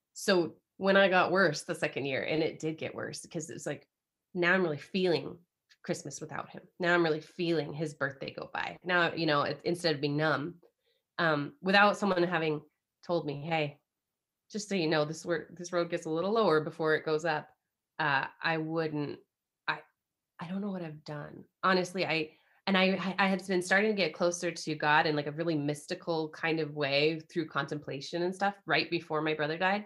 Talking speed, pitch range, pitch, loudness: 205 wpm, 155-180 Hz, 165 Hz, -31 LUFS